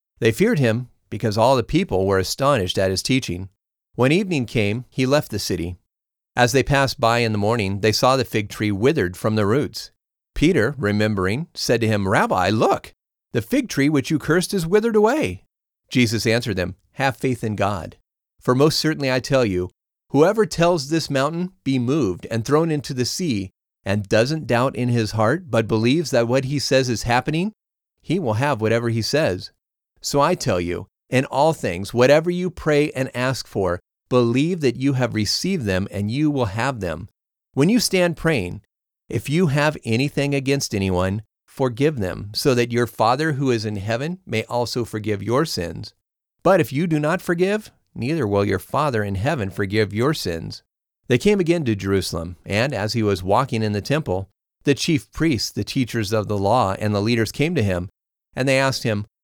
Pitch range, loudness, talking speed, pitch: 105-145 Hz, -21 LUFS, 190 wpm, 120 Hz